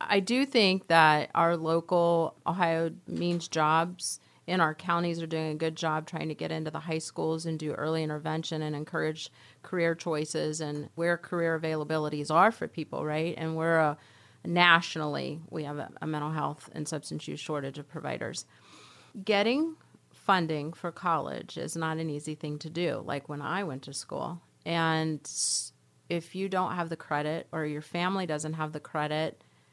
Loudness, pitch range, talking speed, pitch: -30 LUFS, 150-170 Hz, 175 wpm, 160 Hz